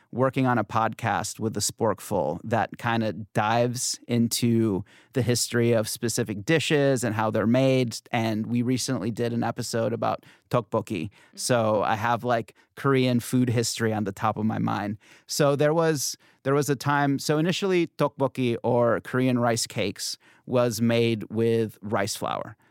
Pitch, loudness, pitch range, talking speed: 120 Hz, -25 LUFS, 110-130 Hz, 160 wpm